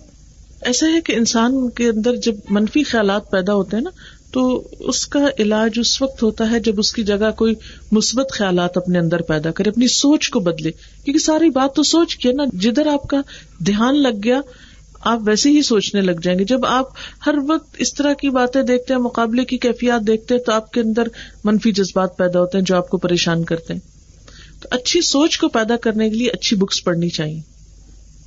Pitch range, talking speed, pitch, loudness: 195-260 Hz, 210 wpm, 230 Hz, -17 LUFS